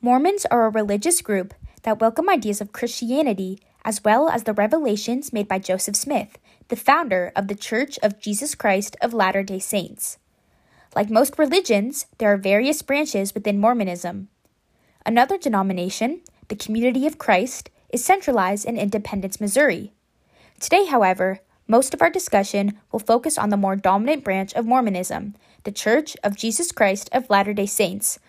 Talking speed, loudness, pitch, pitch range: 160 wpm, -21 LUFS, 215 Hz, 200-260 Hz